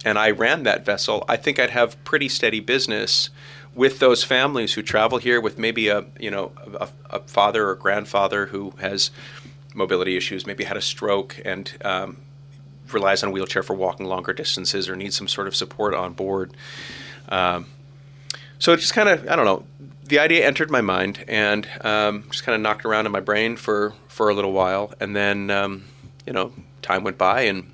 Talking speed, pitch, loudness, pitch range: 200 wpm, 110 Hz, -21 LUFS, 100-140 Hz